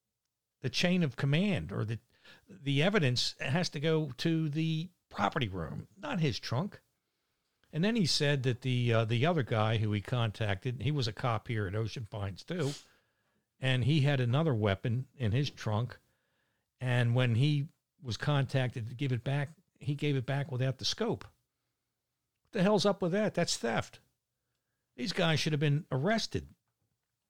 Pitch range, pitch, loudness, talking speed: 115-155 Hz, 130 Hz, -32 LUFS, 170 wpm